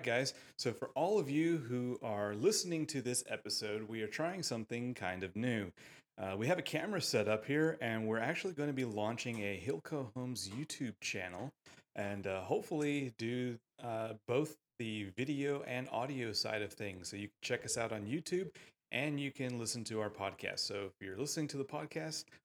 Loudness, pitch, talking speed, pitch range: -39 LUFS, 120 Hz, 200 wpm, 105-145 Hz